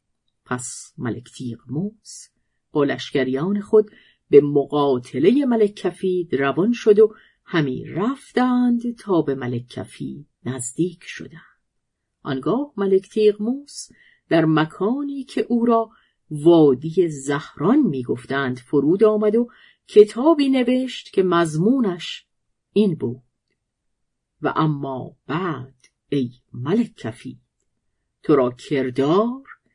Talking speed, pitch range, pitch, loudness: 100 wpm, 135-215 Hz, 170 Hz, -20 LUFS